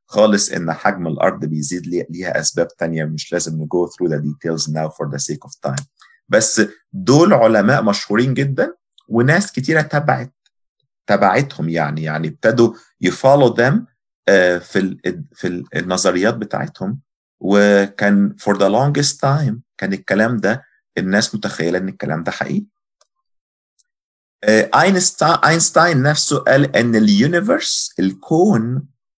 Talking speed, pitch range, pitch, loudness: 120 wpm, 85-145 Hz, 105 Hz, -16 LUFS